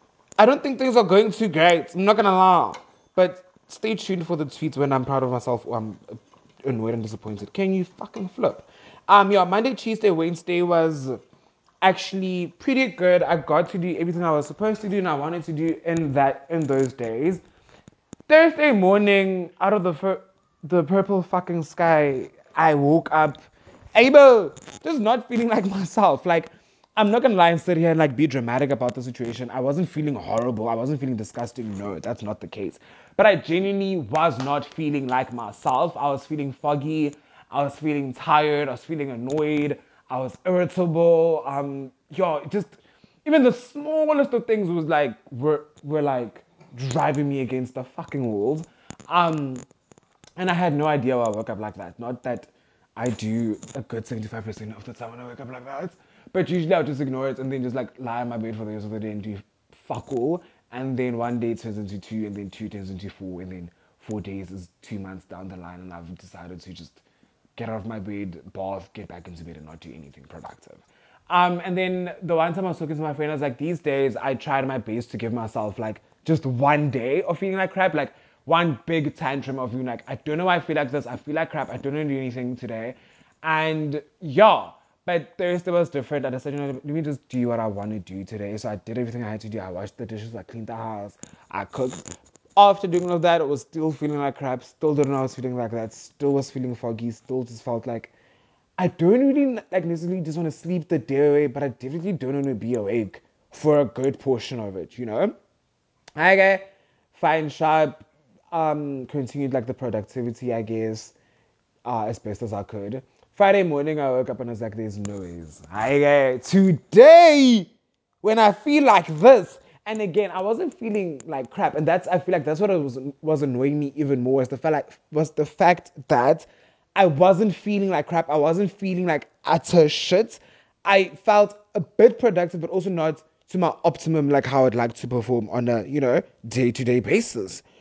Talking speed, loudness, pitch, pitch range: 215 wpm, -22 LUFS, 145 Hz, 120-180 Hz